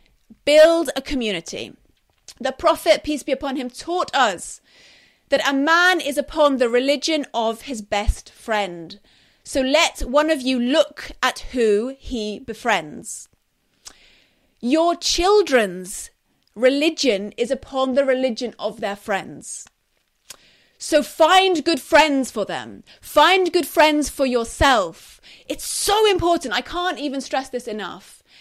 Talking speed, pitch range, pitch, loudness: 130 wpm, 235-315 Hz, 275 Hz, -19 LUFS